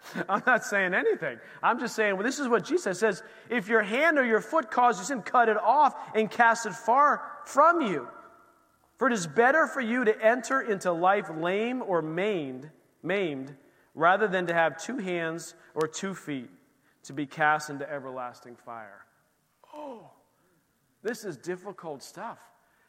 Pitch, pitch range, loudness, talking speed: 215 Hz, 160-250 Hz, -26 LUFS, 170 wpm